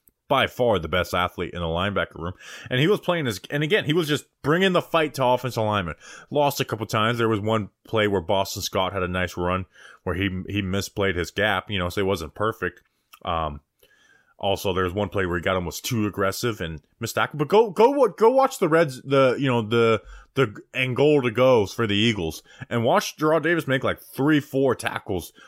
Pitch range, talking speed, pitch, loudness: 95-140 Hz, 225 wpm, 110 Hz, -23 LUFS